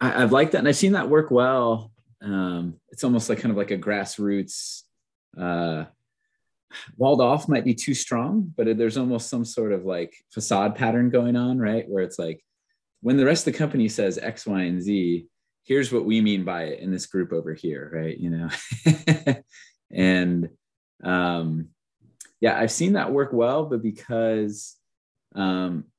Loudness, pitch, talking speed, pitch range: -24 LUFS, 115 Hz, 180 wpm, 95-130 Hz